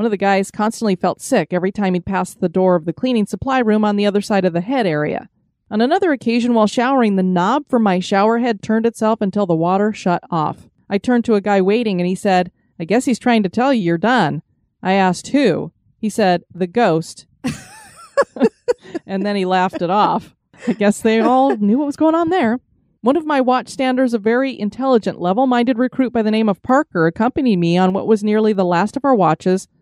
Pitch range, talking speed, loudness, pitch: 185-245 Hz, 225 wpm, -17 LUFS, 215 Hz